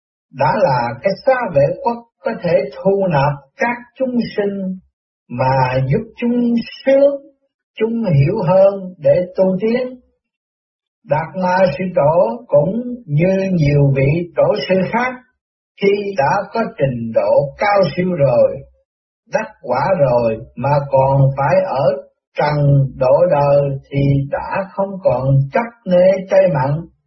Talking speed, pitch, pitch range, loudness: 135 wpm, 185 Hz, 140-230 Hz, -16 LUFS